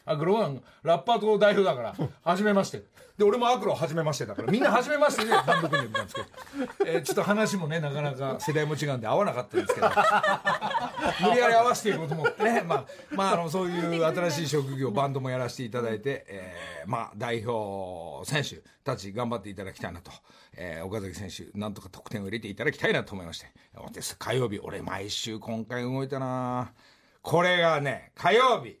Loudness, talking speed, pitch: -27 LUFS, 400 characters per minute, 145 Hz